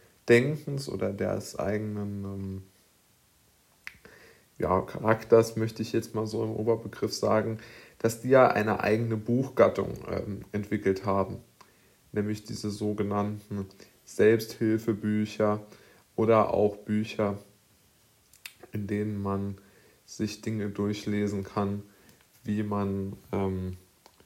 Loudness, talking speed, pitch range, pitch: -29 LUFS, 100 wpm, 100-110 Hz, 105 Hz